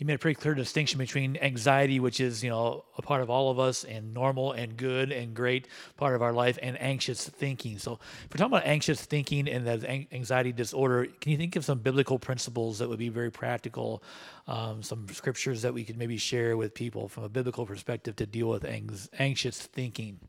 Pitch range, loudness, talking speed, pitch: 115-135 Hz, -30 LUFS, 220 wpm, 125 Hz